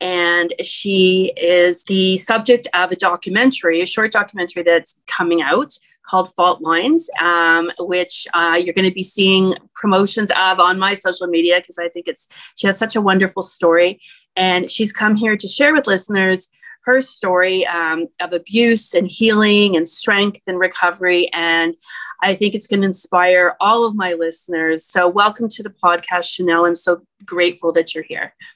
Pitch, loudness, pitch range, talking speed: 185 Hz, -16 LUFS, 175-205 Hz, 175 wpm